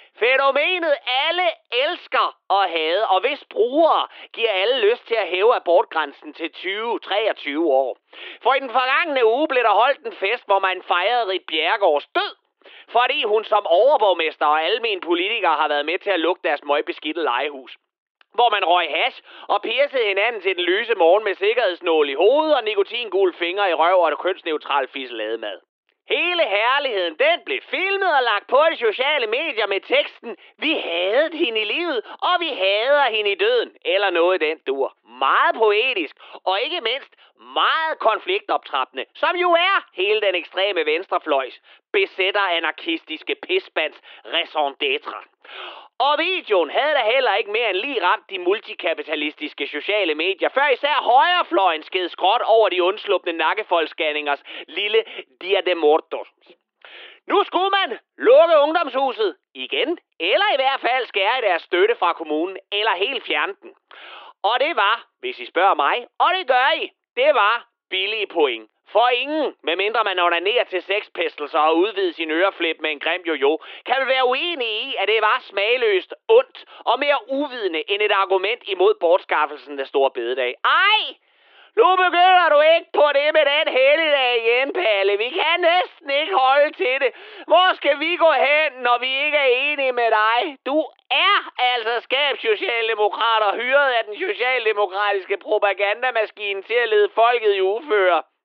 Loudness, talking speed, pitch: -19 LUFS, 160 wpm, 320 Hz